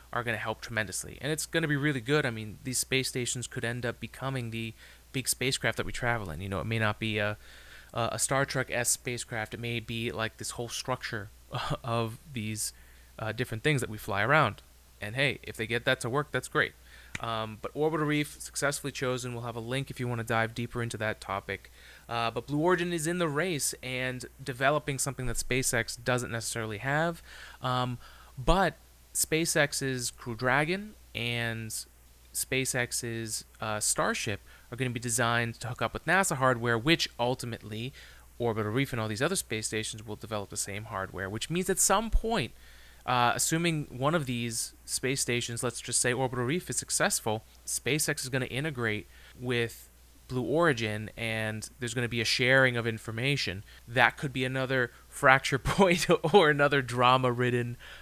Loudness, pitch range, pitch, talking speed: -30 LUFS, 110-135 Hz, 120 Hz, 190 wpm